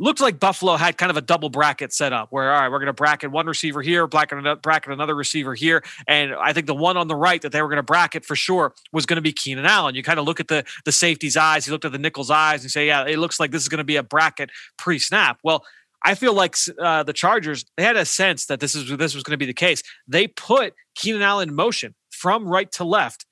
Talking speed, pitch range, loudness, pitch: 275 wpm, 150-170 Hz, -20 LUFS, 155 Hz